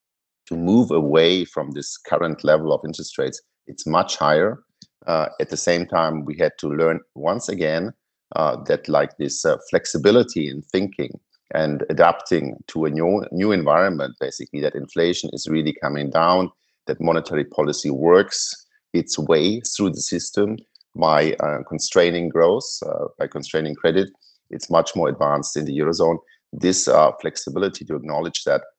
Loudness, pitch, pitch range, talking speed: -21 LUFS, 85 Hz, 80-105 Hz, 160 wpm